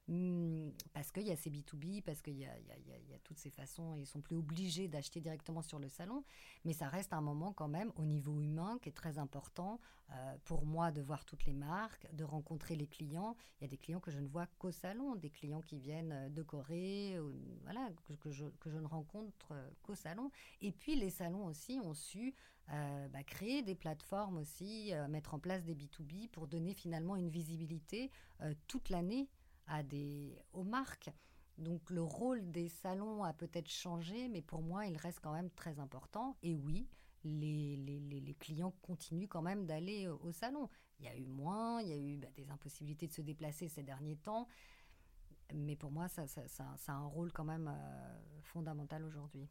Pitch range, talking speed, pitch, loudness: 150-185 Hz, 210 wpm, 160 Hz, -46 LUFS